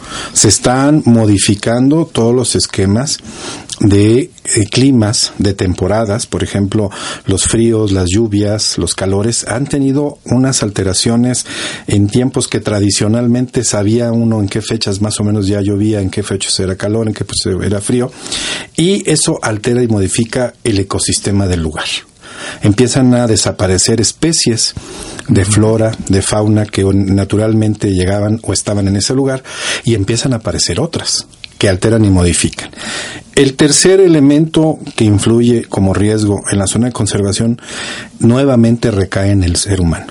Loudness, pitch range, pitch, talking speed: -12 LUFS, 100-120 Hz, 110 Hz, 150 wpm